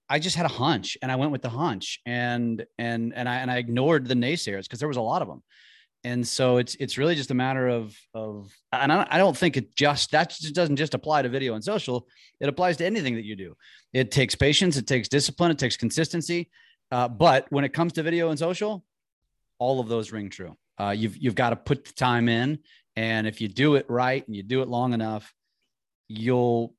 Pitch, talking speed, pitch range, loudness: 130 Hz, 235 wpm, 115-150 Hz, -25 LUFS